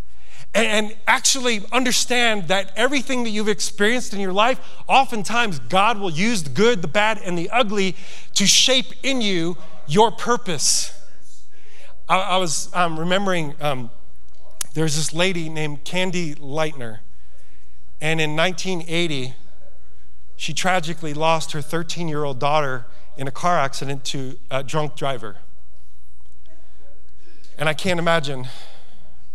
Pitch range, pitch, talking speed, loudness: 135-195 Hz, 160 Hz, 125 wpm, -21 LUFS